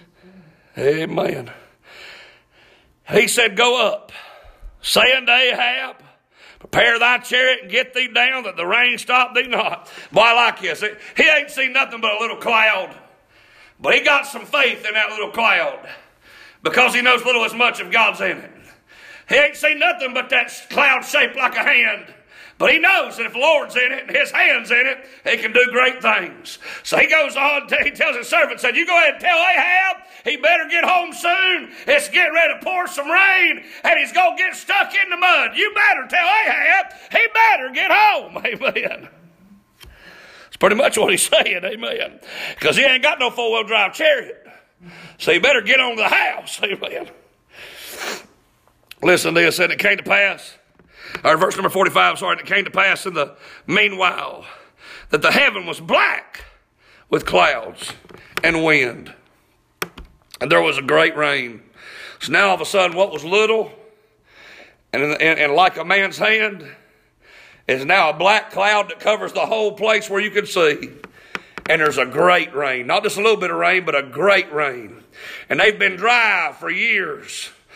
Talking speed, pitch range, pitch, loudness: 185 wpm, 210-305 Hz, 245 Hz, -16 LUFS